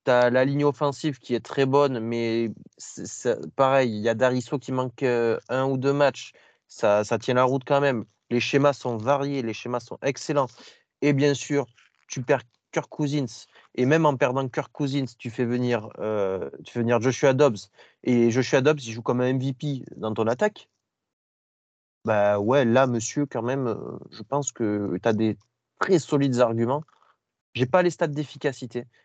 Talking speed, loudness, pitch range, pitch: 190 wpm, -24 LUFS, 115-140 Hz, 130 Hz